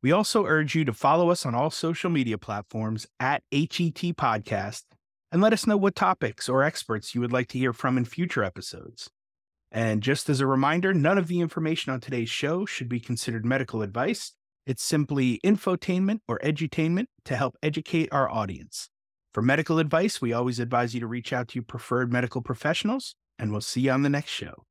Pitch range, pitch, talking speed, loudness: 120-165 Hz, 135 Hz, 200 wpm, -26 LUFS